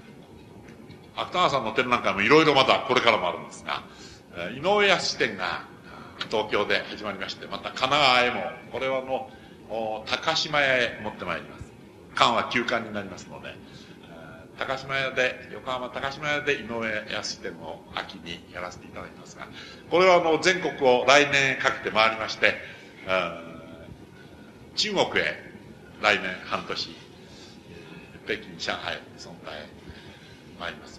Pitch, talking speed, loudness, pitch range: 125 Hz, 265 characters per minute, -24 LUFS, 110-140 Hz